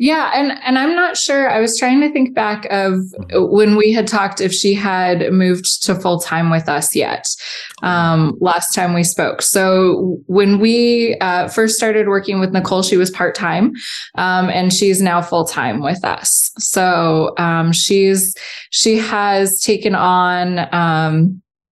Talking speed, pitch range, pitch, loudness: 170 wpm, 180-215 Hz, 190 Hz, -14 LUFS